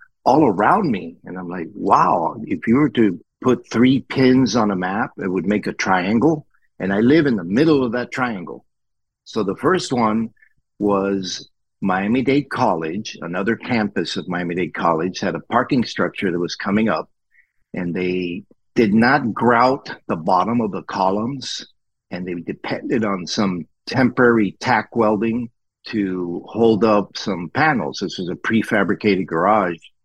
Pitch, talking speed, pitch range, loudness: 105 Hz, 160 wpm, 90-120 Hz, -19 LUFS